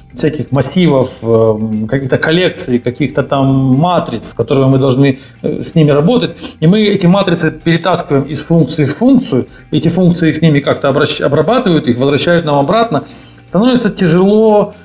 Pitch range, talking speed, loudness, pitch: 135-175 Hz, 135 wpm, -11 LUFS, 150 Hz